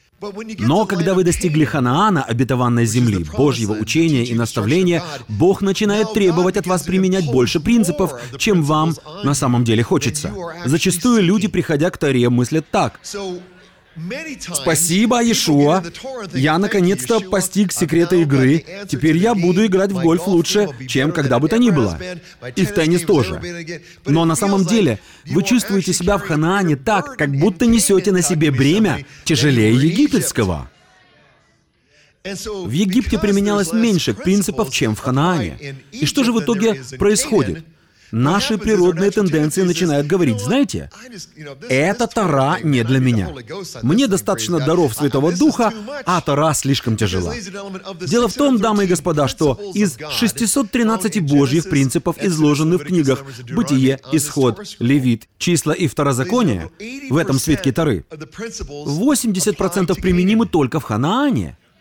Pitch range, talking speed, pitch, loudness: 140-200 Hz, 135 wpm, 175 Hz, -17 LUFS